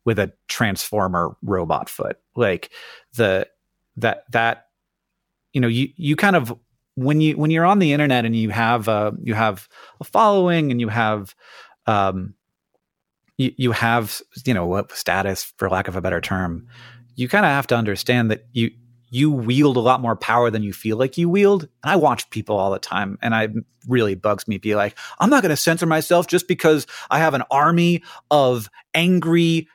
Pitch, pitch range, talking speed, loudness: 120 Hz, 110-155 Hz, 190 wpm, -20 LUFS